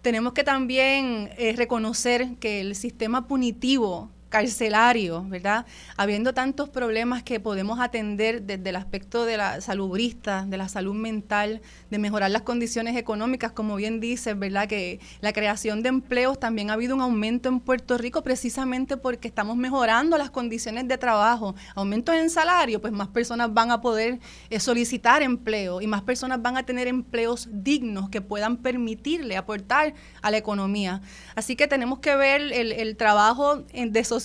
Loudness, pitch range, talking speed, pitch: -25 LUFS, 210-255 Hz, 160 wpm, 235 Hz